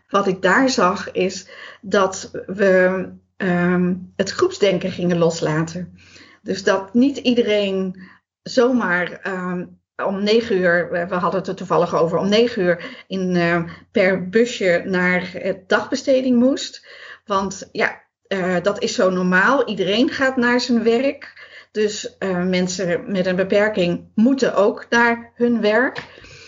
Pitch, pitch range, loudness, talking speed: 195 Hz, 180-235 Hz, -19 LUFS, 140 wpm